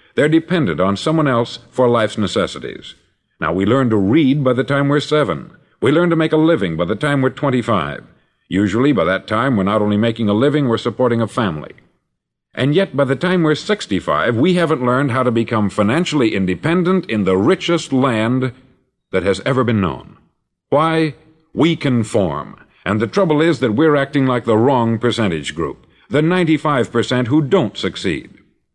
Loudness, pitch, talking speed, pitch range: -16 LUFS, 130 Hz, 180 wpm, 115-155 Hz